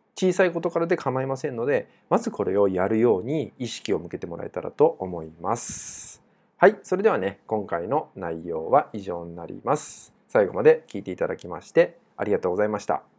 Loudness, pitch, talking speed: -25 LUFS, 120 Hz, 390 characters per minute